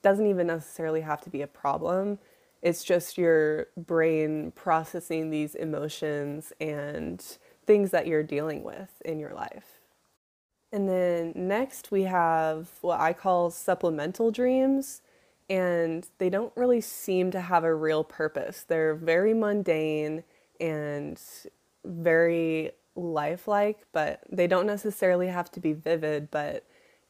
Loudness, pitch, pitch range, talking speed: -28 LUFS, 170 Hz, 155-190 Hz, 130 wpm